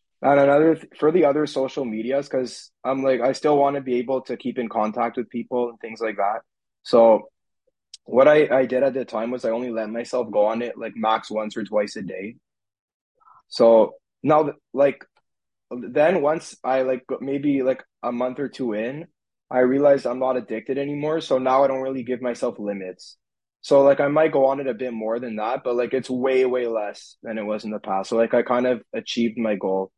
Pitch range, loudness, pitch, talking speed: 115-135 Hz, -22 LUFS, 125 Hz, 220 wpm